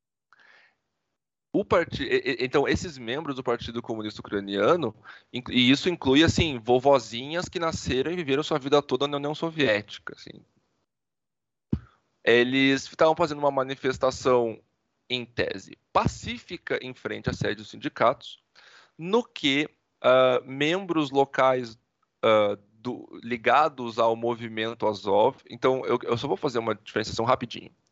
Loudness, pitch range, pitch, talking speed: -25 LUFS, 120-145 Hz, 130 Hz, 125 wpm